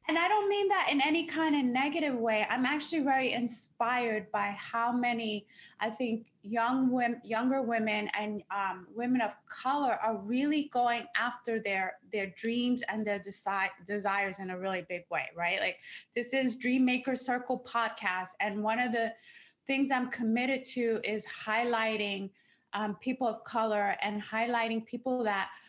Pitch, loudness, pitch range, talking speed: 230 Hz, -32 LUFS, 210-255 Hz, 165 wpm